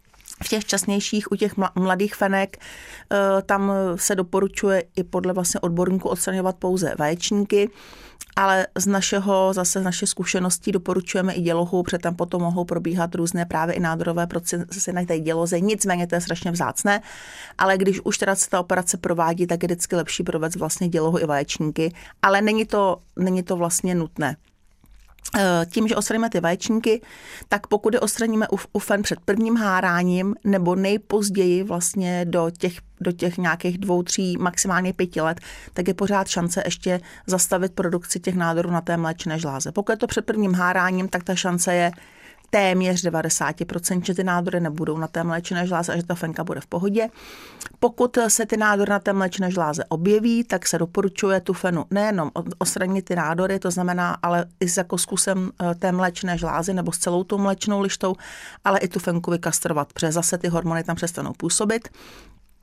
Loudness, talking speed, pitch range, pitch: -22 LUFS, 175 wpm, 175-195 Hz, 185 Hz